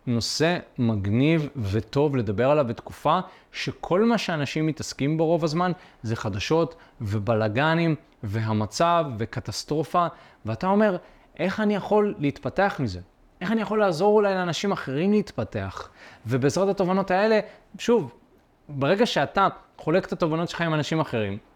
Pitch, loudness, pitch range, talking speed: 155 Hz, -24 LUFS, 120-185 Hz, 130 wpm